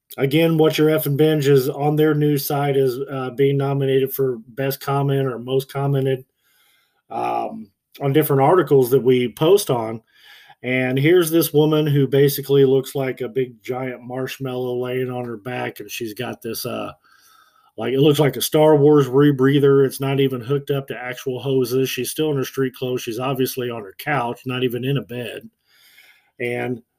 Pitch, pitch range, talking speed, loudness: 135 Hz, 125-140 Hz, 180 wpm, -19 LUFS